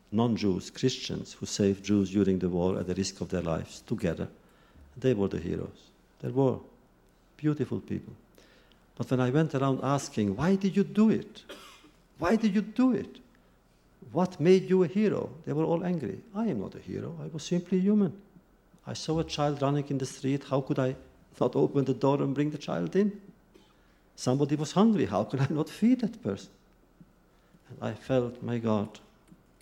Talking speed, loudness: 190 wpm, -29 LUFS